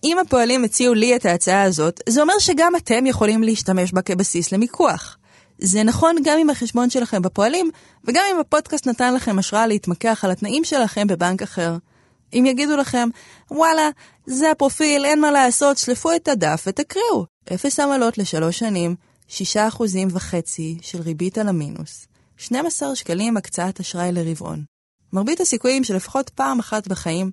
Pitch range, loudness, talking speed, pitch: 185-280 Hz, -19 LUFS, 155 wpm, 225 Hz